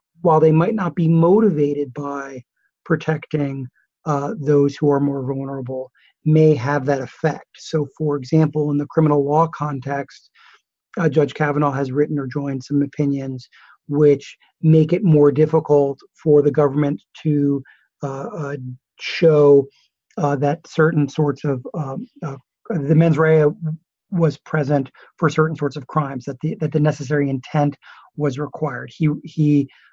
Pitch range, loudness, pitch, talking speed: 140-155 Hz, -19 LUFS, 145 Hz, 150 wpm